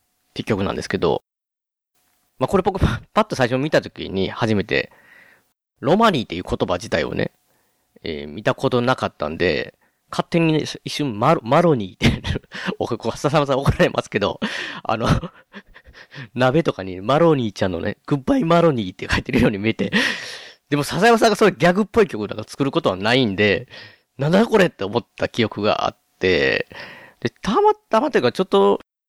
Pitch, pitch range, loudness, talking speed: 145 Hz, 110-175 Hz, -20 LUFS, 355 characters per minute